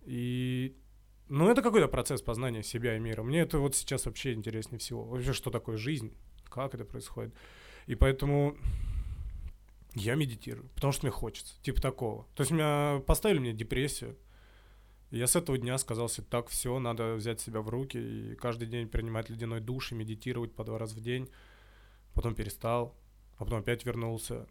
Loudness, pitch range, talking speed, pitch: -33 LUFS, 110-130 Hz, 175 wpm, 120 Hz